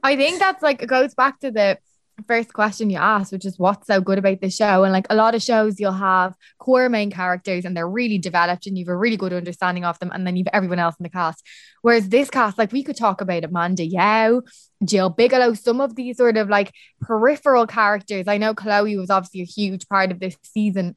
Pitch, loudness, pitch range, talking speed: 205 Hz, -19 LUFS, 185-230 Hz, 245 wpm